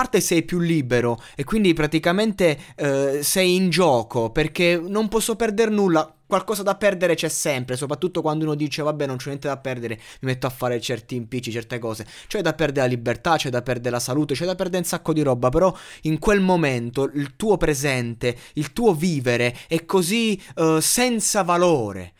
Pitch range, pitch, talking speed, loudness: 130-180 Hz, 155 Hz, 195 wpm, -21 LUFS